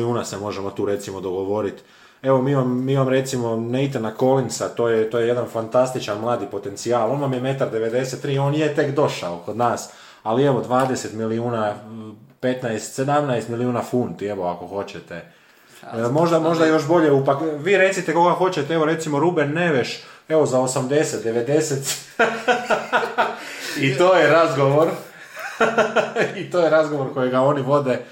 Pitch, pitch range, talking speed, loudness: 130 Hz, 115-155 Hz, 150 wpm, -20 LUFS